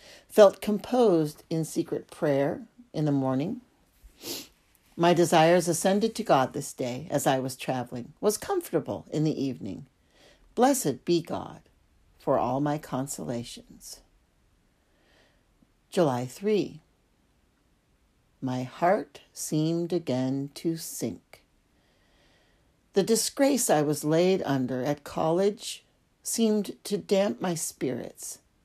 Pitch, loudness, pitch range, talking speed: 160 Hz, -27 LUFS, 130-200 Hz, 110 wpm